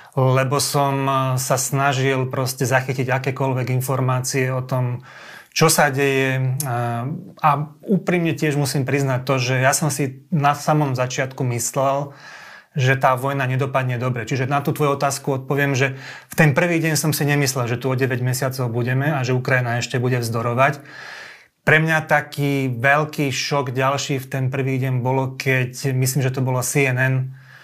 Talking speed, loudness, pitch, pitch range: 165 wpm, -20 LUFS, 135 Hz, 130-145 Hz